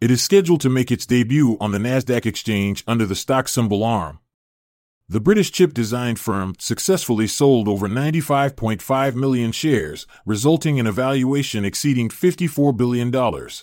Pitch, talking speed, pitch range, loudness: 125 Hz, 150 wpm, 110-140 Hz, -19 LUFS